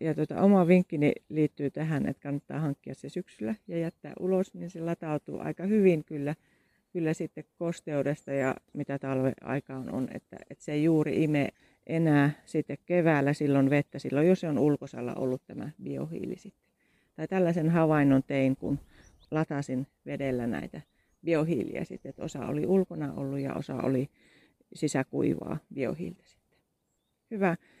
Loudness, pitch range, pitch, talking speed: -30 LUFS, 140-165 Hz, 150 Hz, 145 wpm